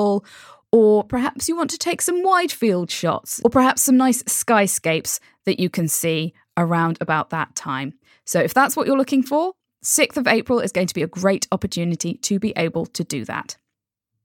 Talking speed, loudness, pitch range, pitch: 195 wpm, -20 LUFS, 165-260 Hz, 200 Hz